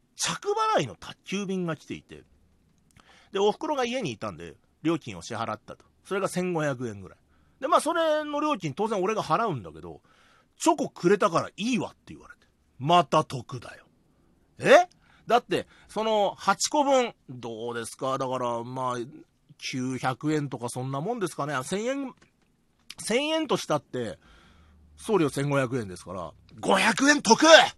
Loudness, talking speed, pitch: -26 LUFS, 270 characters per minute, 150 Hz